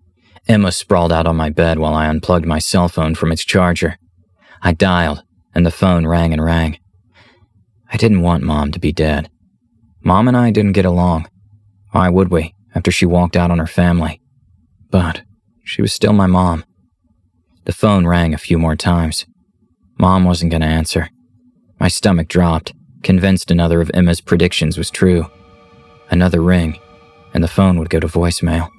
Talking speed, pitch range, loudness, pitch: 170 wpm, 85-95 Hz, -15 LUFS, 90 Hz